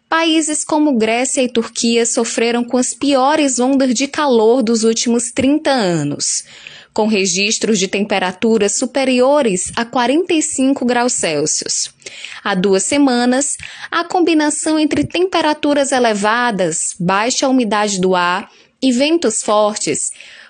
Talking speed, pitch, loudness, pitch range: 115 wpm, 245 Hz, -15 LUFS, 215-285 Hz